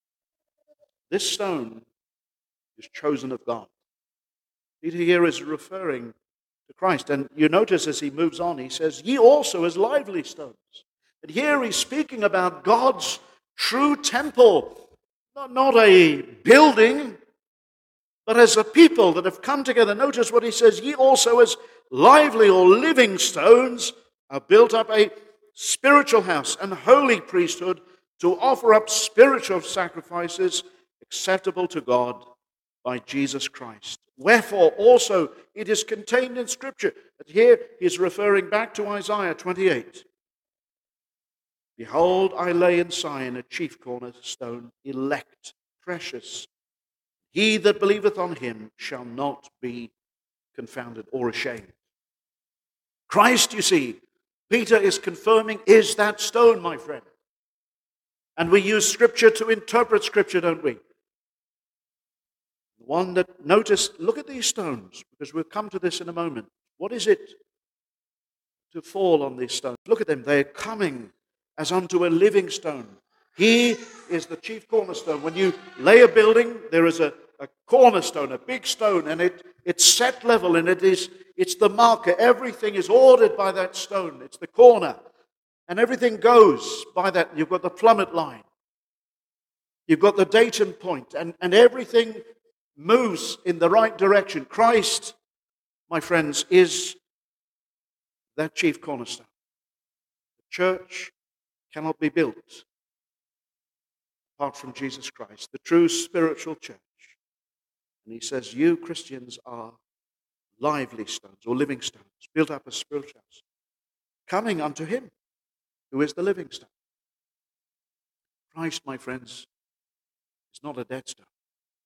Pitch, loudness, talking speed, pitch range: 205 Hz, -20 LUFS, 140 wpm, 160-265 Hz